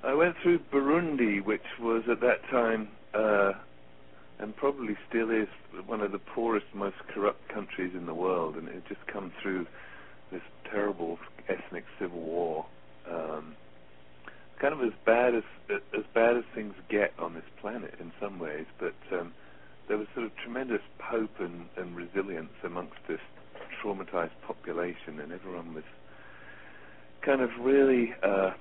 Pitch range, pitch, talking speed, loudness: 75-115 Hz, 95 Hz, 155 wpm, -31 LUFS